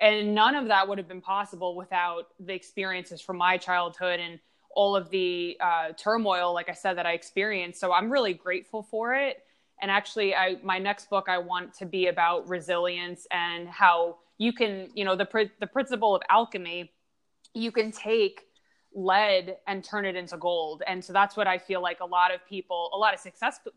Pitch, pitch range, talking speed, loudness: 190 Hz, 180-210 Hz, 200 wpm, -27 LUFS